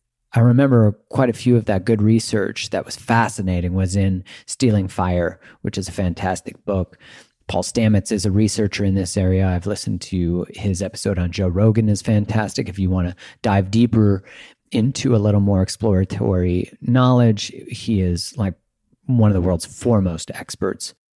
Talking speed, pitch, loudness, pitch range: 170 wpm, 100 Hz, -19 LUFS, 95-115 Hz